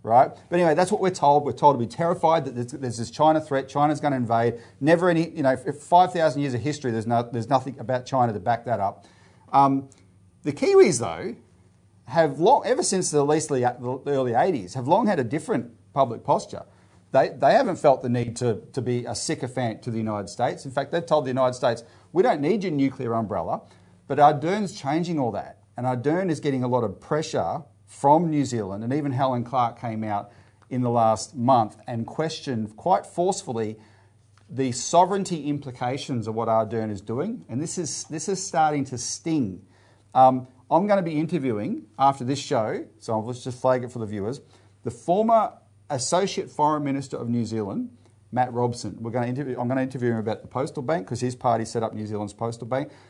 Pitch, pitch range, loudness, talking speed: 130 Hz, 115-150 Hz, -24 LUFS, 205 wpm